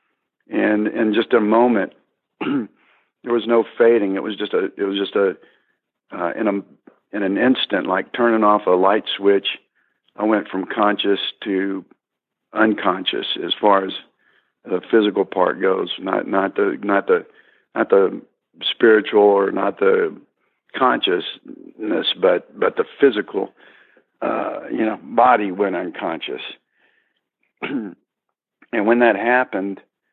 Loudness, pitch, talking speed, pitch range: -19 LUFS, 110 Hz, 135 wpm, 100-125 Hz